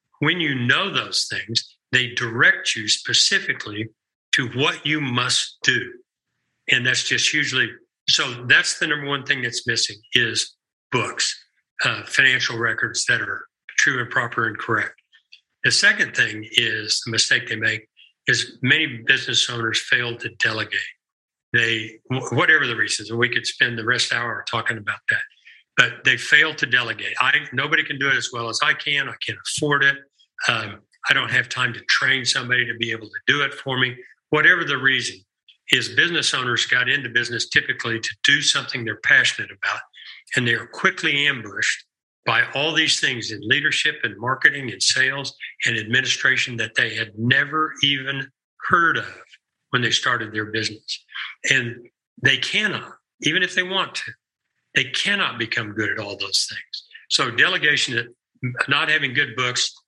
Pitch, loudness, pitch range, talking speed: 125 Hz, -20 LUFS, 115-140 Hz, 170 wpm